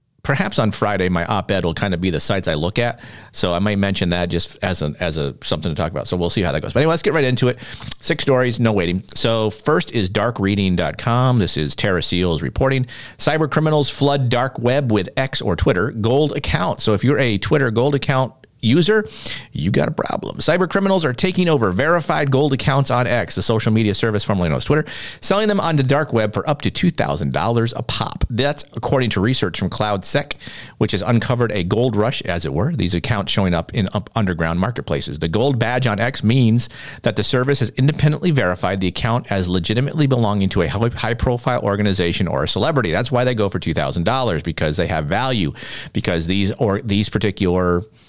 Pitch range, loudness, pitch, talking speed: 95-130 Hz, -19 LUFS, 115 Hz, 210 wpm